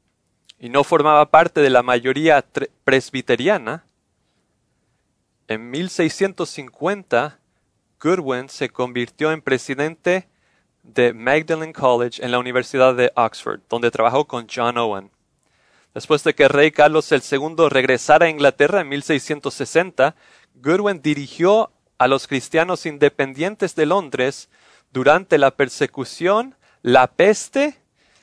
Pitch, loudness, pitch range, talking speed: 140 Hz, -18 LUFS, 125-160 Hz, 110 wpm